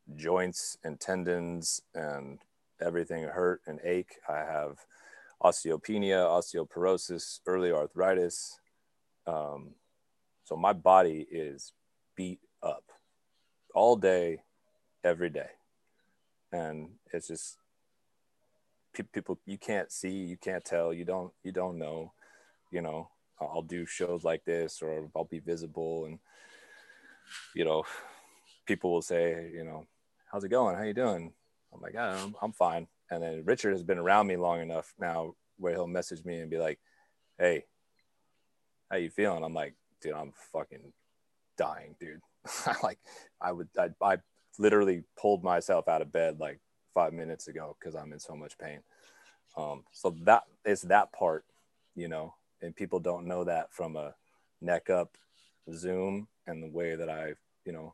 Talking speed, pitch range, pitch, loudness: 150 wpm, 80-95 Hz, 85 Hz, -32 LUFS